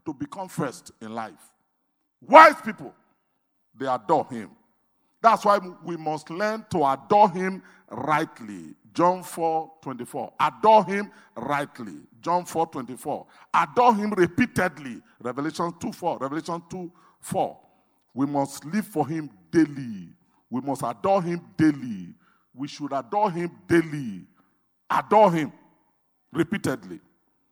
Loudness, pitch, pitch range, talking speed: -23 LUFS, 175 Hz, 155-205 Hz, 120 wpm